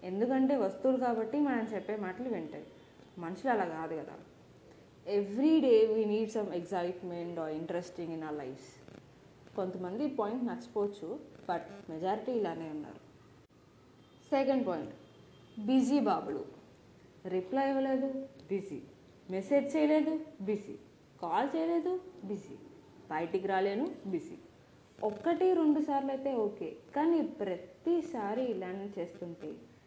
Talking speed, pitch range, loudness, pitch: 110 wpm, 180-270 Hz, -34 LUFS, 210 Hz